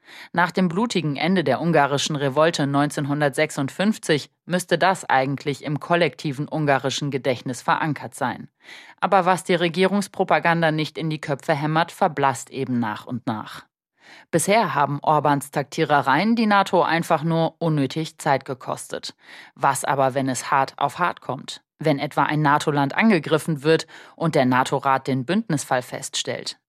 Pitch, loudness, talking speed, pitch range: 155 Hz, -22 LUFS, 140 wpm, 140-175 Hz